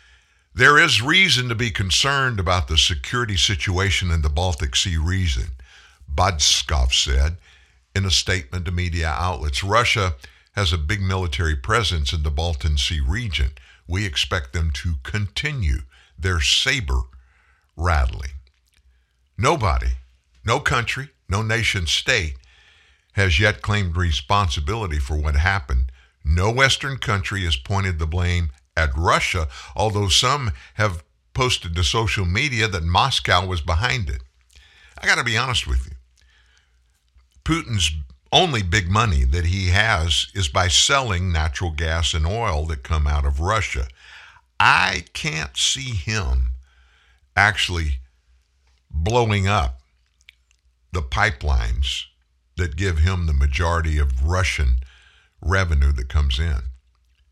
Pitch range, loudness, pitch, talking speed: 70-95 Hz, -20 LUFS, 85 Hz, 130 wpm